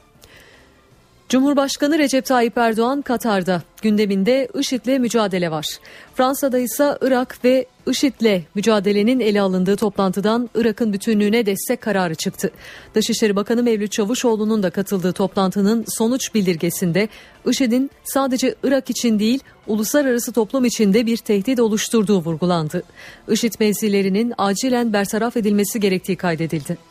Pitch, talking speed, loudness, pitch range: 220 Hz, 115 wpm, -19 LUFS, 200-245 Hz